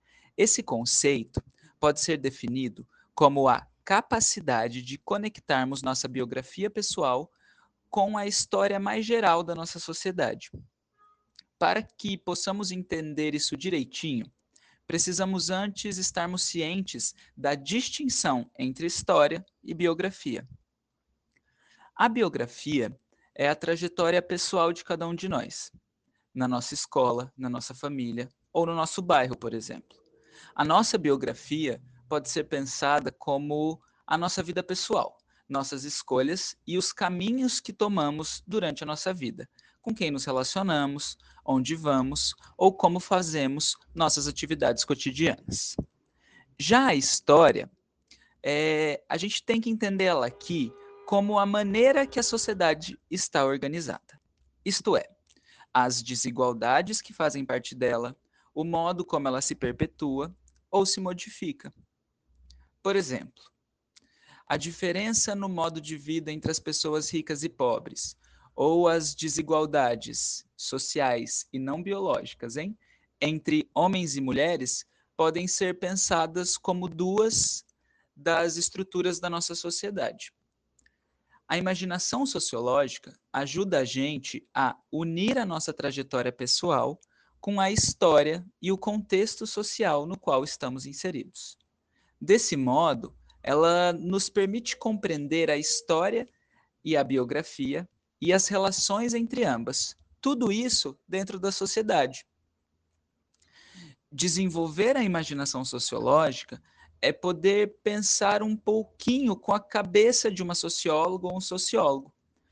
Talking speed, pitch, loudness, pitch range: 120 wpm, 170 Hz, -27 LUFS, 140-195 Hz